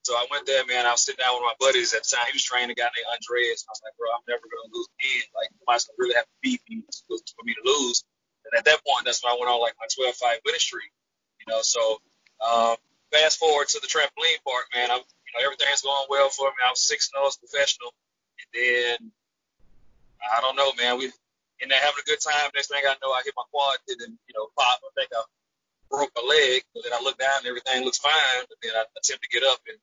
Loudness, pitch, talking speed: -23 LUFS, 140 Hz, 270 wpm